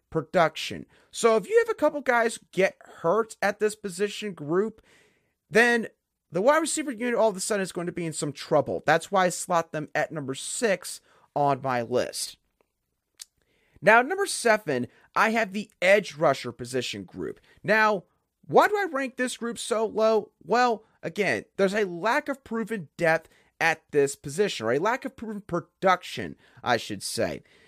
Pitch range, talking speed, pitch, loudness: 160-225 Hz, 175 wpm, 200 Hz, -26 LUFS